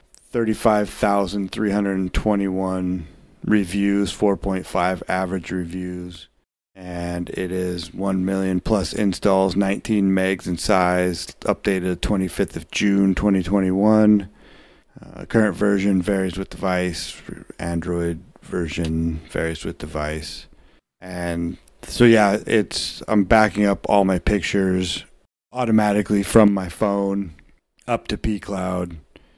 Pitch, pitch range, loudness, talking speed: 95 Hz, 90-100 Hz, -21 LUFS, 100 wpm